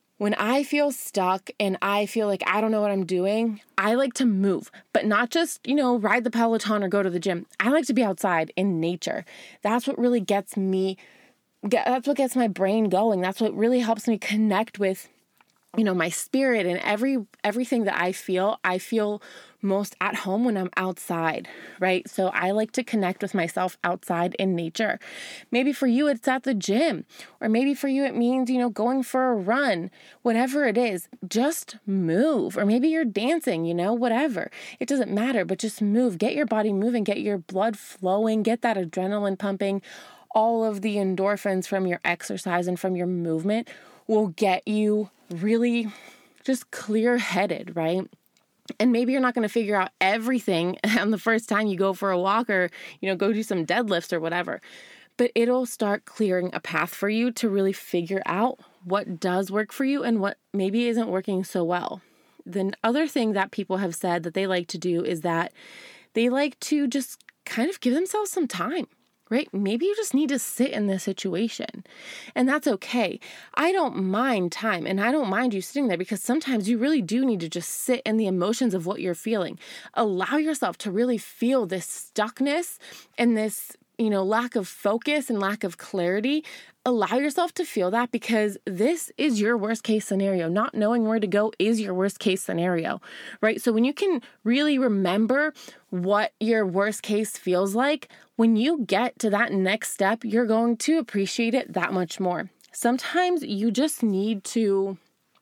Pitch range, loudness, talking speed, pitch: 190-245 Hz, -25 LUFS, 195 wpm, 215 Hz